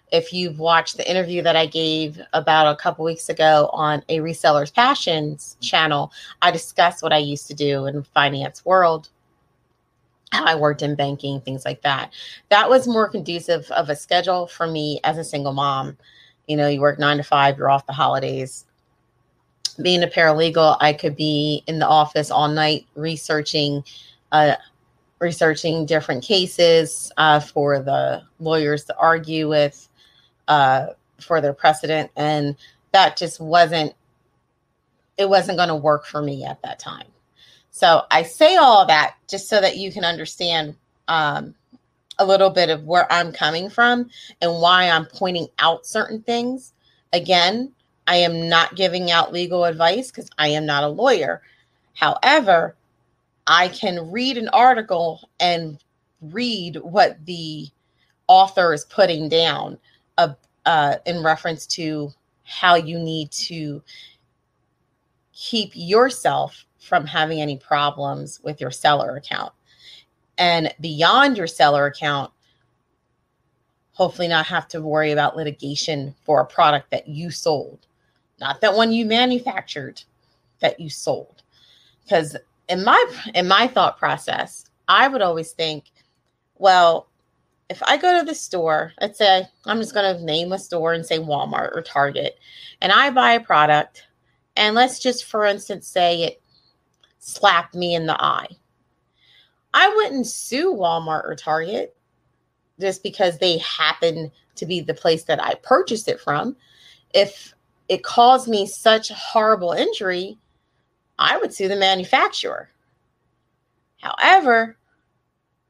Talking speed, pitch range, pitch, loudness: 145 wpm, 150-195 Hz, 165 Hz, -19 LUFS